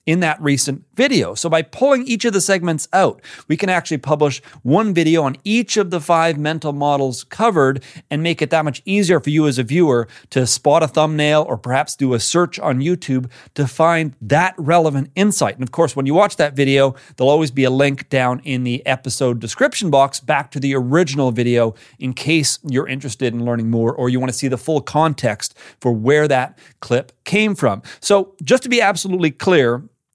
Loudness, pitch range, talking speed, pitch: -17 LUFS, 130-170 Hz, 205 wpm, 145 Hz